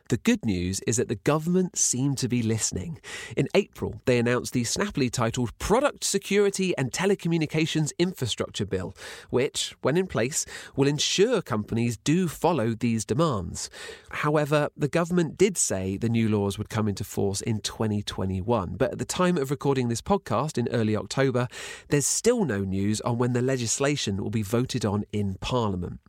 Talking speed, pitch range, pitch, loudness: 170 wpm, 110-155 Hz, 125 Hz, -26 LUFS